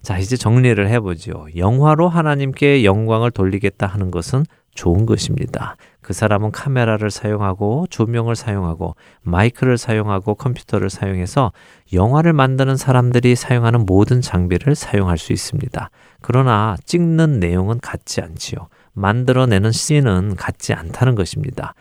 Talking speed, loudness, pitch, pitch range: 340 characters per minute, -17 LUFS, 110 Hz, 100-130 Hz